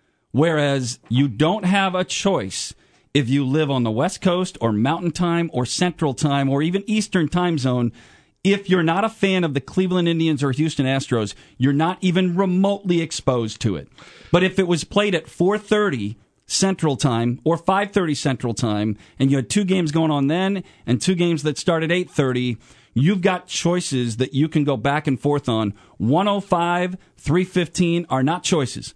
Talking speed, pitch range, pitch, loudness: 180 wpm, 130-180 Hz, 155 Hz, -20 LUFS